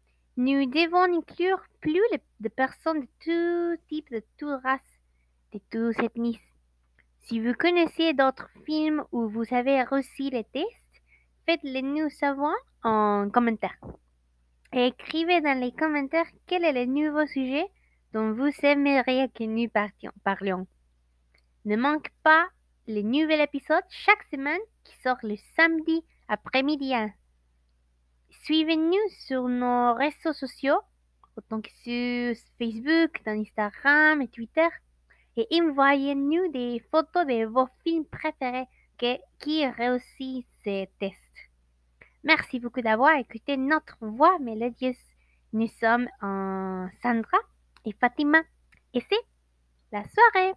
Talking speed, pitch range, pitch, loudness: 125 wpm, 220-310 Hz, 260 Hz, -26 LUFS